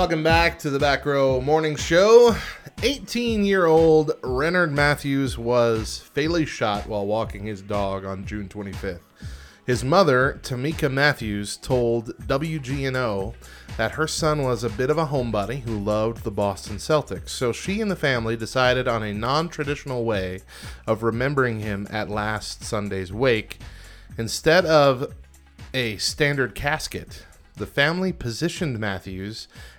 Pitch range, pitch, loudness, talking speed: 105-150 Hz, 120 Hz, -22 LUFS, 135 wpm